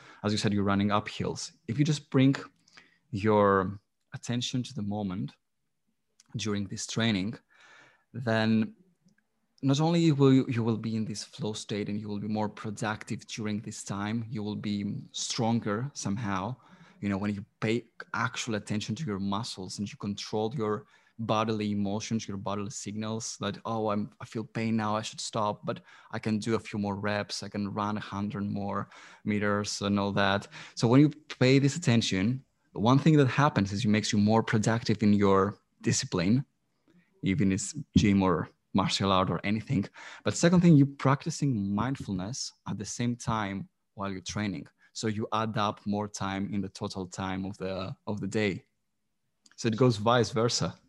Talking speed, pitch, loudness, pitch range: 180 wpm, 105 Hz, -29 LUFS, 100-120 Hz